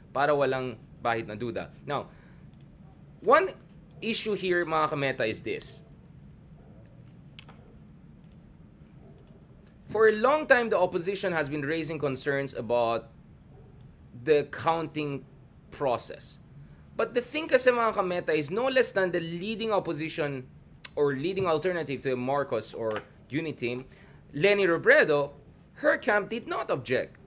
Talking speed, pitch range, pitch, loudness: 120 wpm, 135-200 Hz, 160 Hz, -28 LUFS